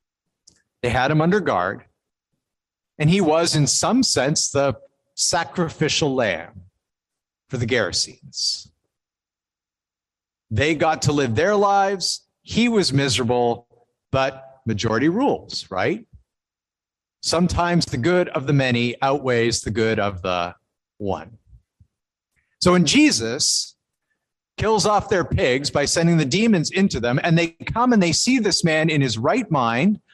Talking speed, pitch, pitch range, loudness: 135 wpm, 145 Hz, 120-175 Hz, -20 LUFS